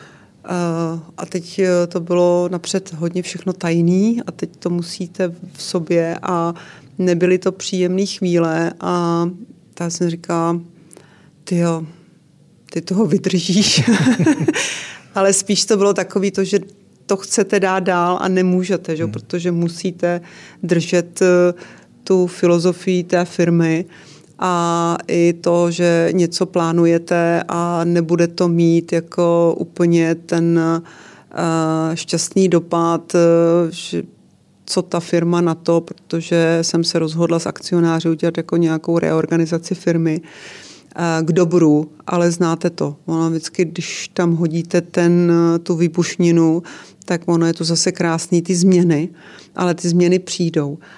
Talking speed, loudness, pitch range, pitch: 125 wpm, -17 LUFS, 165-180 Hz, 175 Hz